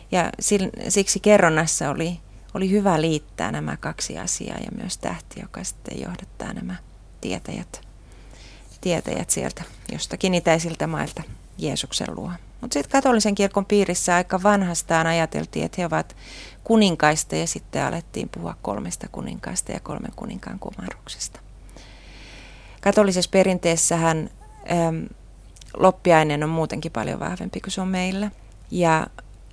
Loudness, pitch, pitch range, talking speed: -22 LUFS, 170 Hz, 155-195 Hz, 120 wpm